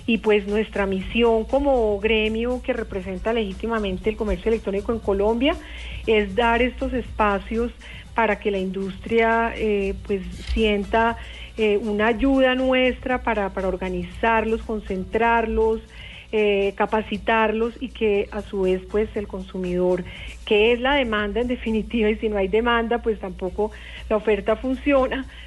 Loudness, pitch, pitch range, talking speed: -22 LUFS, 220 Hz, 205-230 Hz, 140 wpm